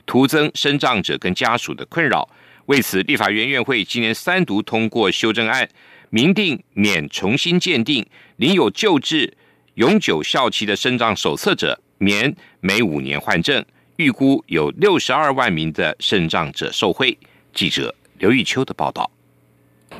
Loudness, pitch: -18 LUFS, 125 Hz